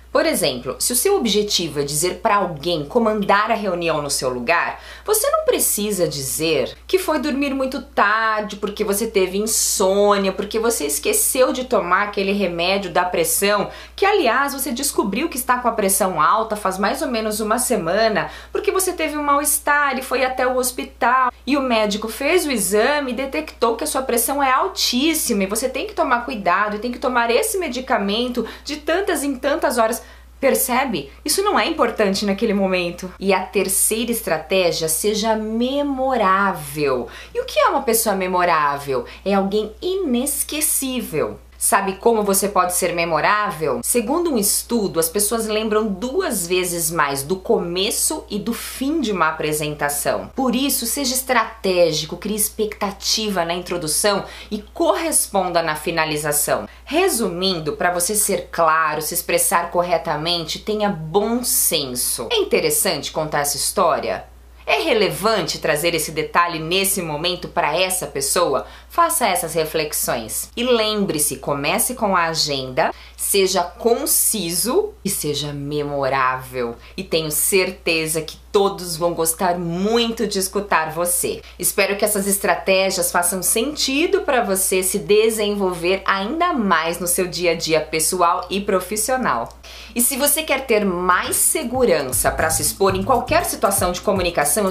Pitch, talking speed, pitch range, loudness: 205 Hz, 150 wpm, 175-250 Hz, -19 LUFS